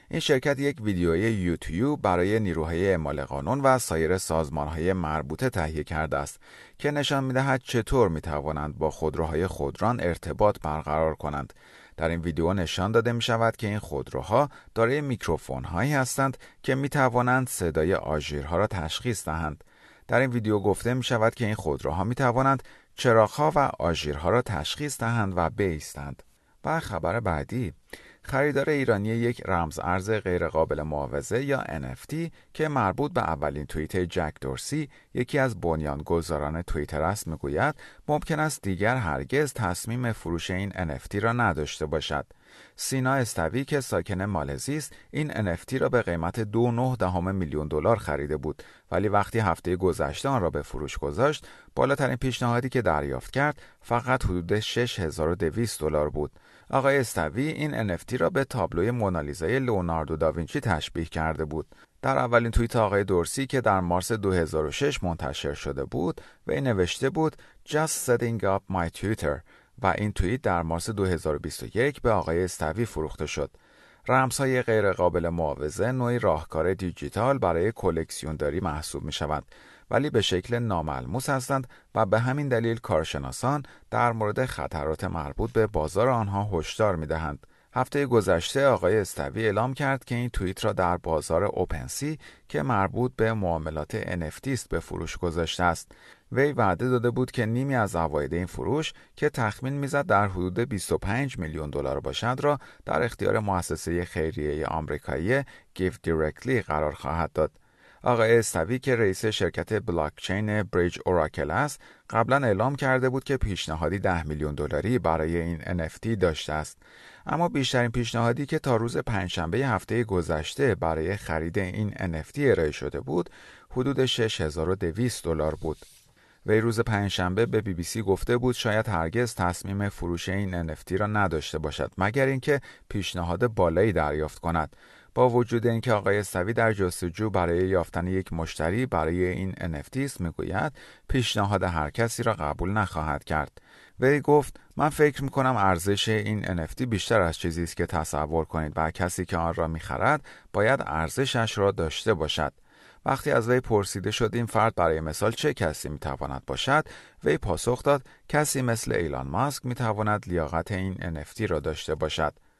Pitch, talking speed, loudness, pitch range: 95 Hz, 155 wpm, -27 LUFS, 80-120 Hz